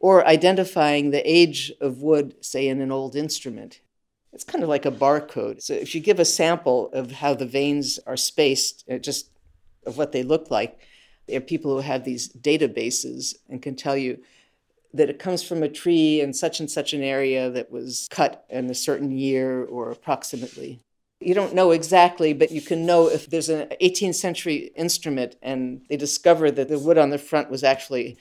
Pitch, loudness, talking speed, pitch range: 145 Hz, -22 LUFS, 195 wpm, 135-165 Hz